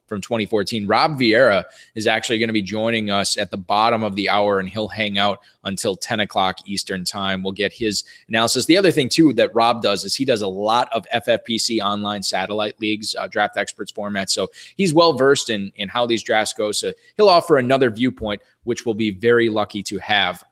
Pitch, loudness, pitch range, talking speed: 110 Hz, -19 LUFS, 100-115 Hz, 215 wpm